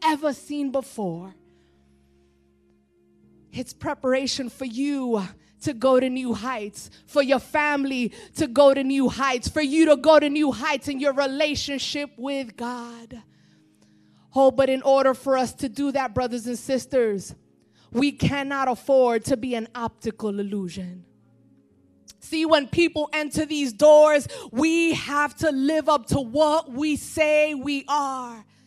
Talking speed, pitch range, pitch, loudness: 145 wpm, 230-290 Hz, 270 Hz, -23 LUFS